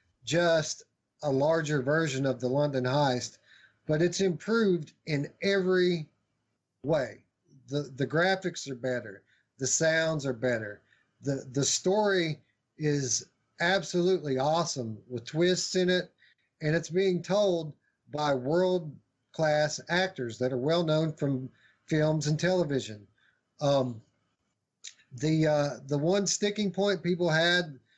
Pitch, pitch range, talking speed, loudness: 150 Hz, 130-175 Hz, 125 wpm, -29 LUFS